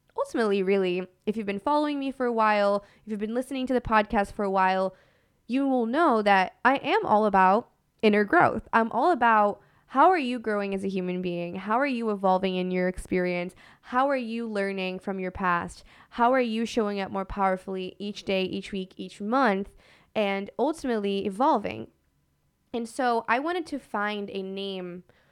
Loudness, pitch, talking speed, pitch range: -26 LUFS, 210 Hz, 185 wpm, 190-240 Hz